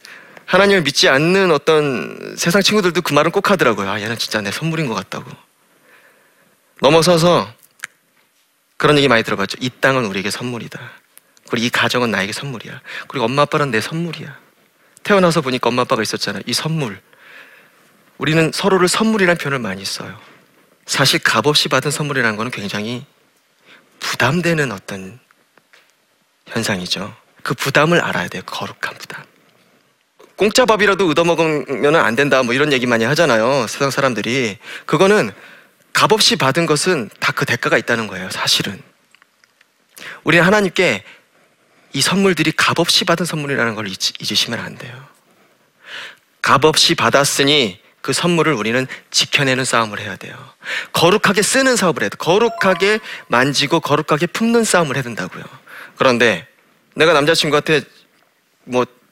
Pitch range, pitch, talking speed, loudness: 125-175 Hz, 150 Hz, 330 characters per minute, -15 LUFS